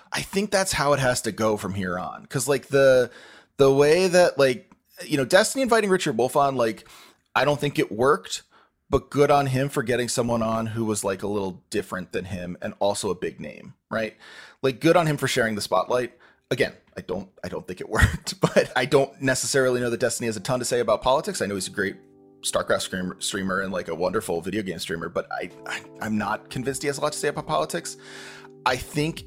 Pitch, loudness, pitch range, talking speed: 130 Hz, -24 LUFS, 110-145 Hz, 235 wpm